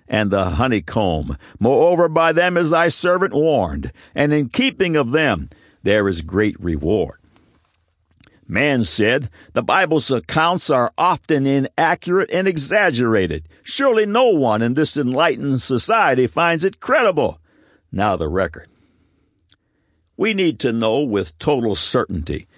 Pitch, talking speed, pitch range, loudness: 145 Hz, 130 wpm, 110-170 Hz, -18 LUFS